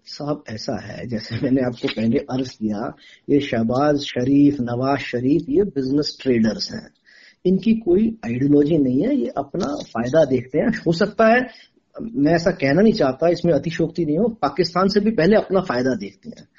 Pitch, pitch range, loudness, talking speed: 145 Hz, 125-185 Hz, -20 LUFS, 175 wpm